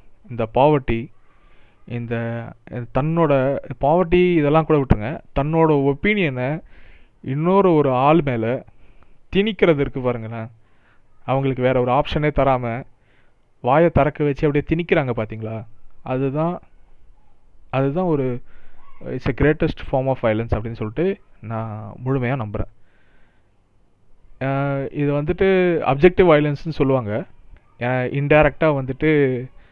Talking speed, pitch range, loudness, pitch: 95 wpm, 115-150 Hz, -20 LUFS, 130 Hz